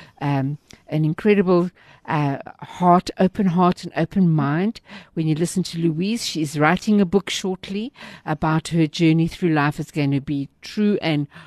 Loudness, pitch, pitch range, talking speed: -21 LUFS, 165 Hz, 155-185 Hz, 160 wpm